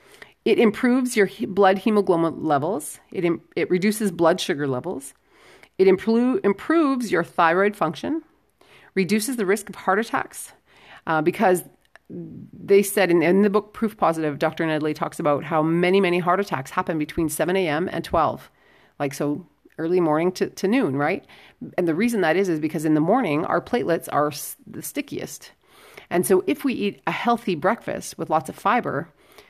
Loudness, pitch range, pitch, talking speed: -22 LUFS, 165-210 Hz, 185 Hz, 170 wpm